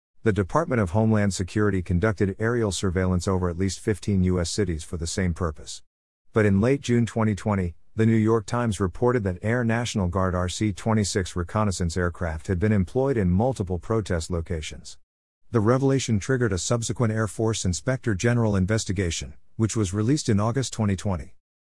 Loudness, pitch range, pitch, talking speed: -24 LUFS, 90-110 Hz, 100 Hz, 165 wpm